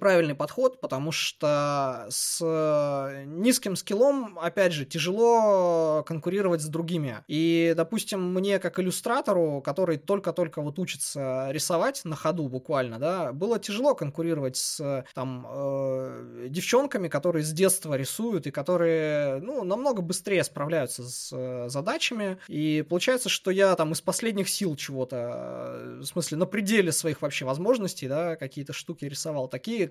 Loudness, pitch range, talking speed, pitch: -27 LUFS, 145-190 Hz, 135 wpm, 165 Hz